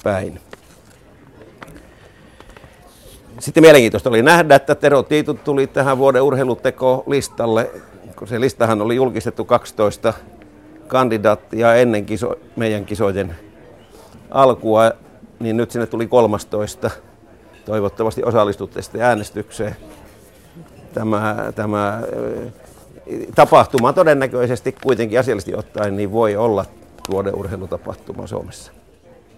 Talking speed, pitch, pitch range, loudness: 95 wpm, 115 Hz, 105-130 Hz, -16 LUFS